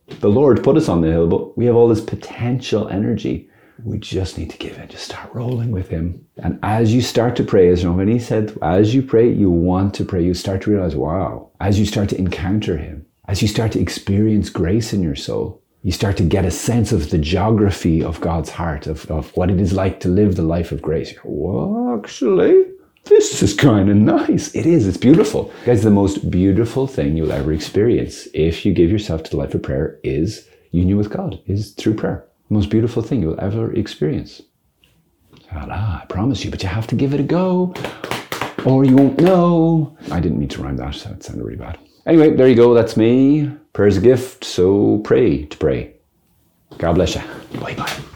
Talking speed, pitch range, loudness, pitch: 220 wpm, 90-120 Hz, -17 LUFS, 105 Hz